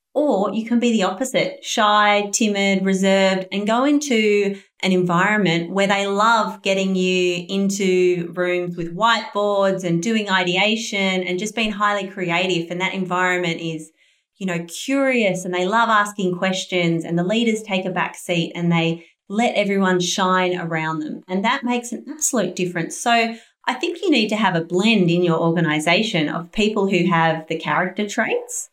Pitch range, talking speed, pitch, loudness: 180-220 Hz, 170 wpm, 190 Hz, -19 LUFS